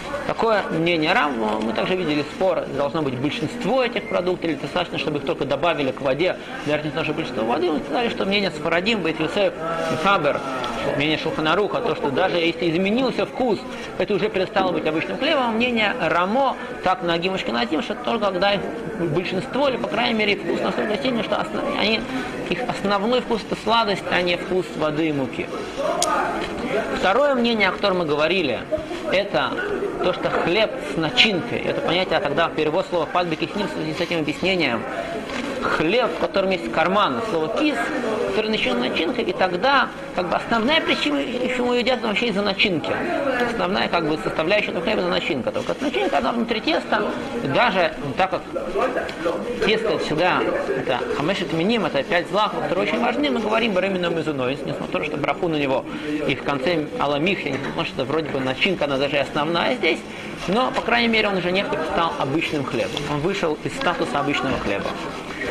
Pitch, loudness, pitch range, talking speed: 185 Hz, -22 LUFS, 160-230 Hz, 180 wpm